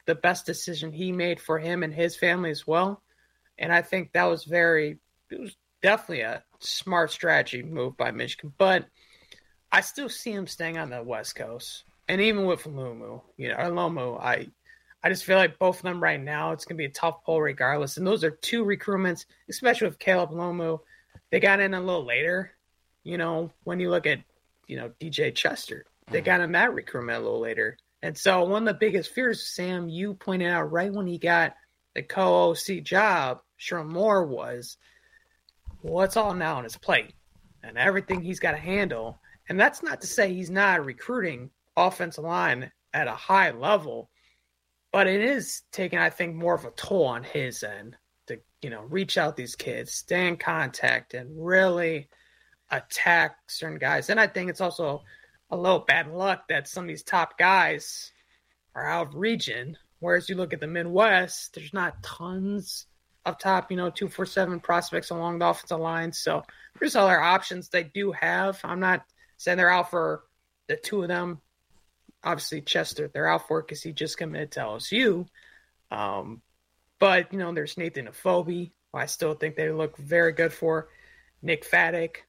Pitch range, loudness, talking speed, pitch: 160-190 Hz, -26 LUFS, 190 wpm, 175 Hz